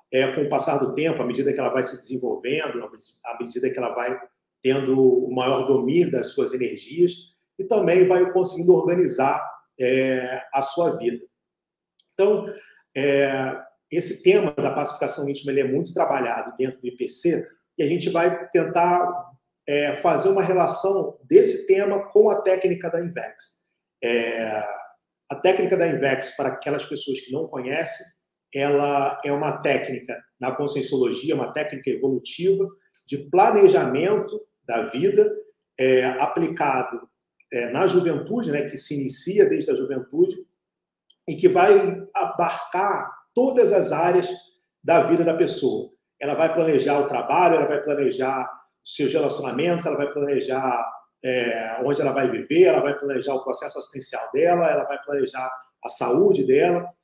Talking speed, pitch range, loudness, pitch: 150 wpm, 140-210 Hz, -22 LUFS, 170 Hz